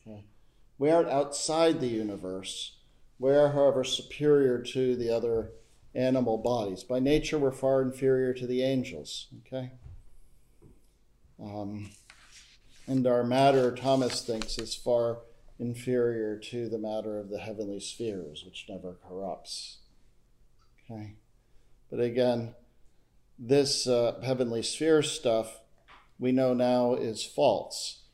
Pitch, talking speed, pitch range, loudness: 120 Hz, 115 wpm, 110-130 Hz, -29 LUFS